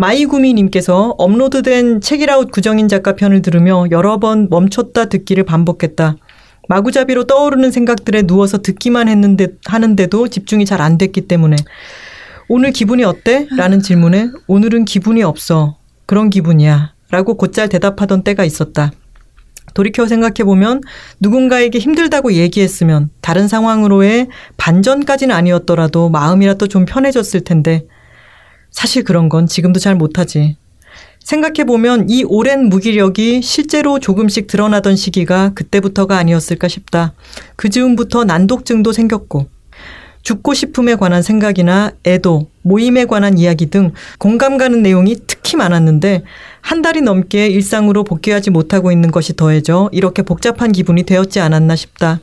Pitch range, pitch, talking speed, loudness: 175-230 Hz, 195 Hz, 345 characters per minute, -11 LUFS